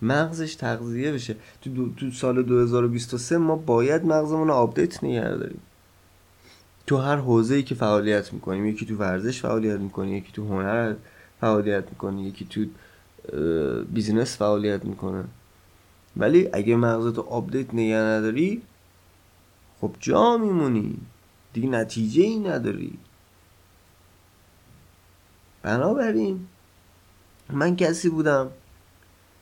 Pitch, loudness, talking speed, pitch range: 110 Hz, -24 LUFS, 105 wpm, 95-125 Hz